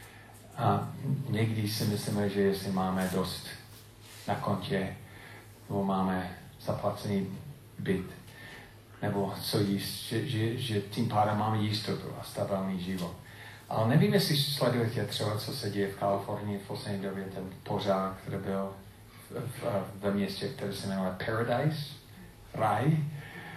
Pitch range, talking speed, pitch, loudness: 100-115 Hz, 130 wpm, 105 Hz, -32 LUFS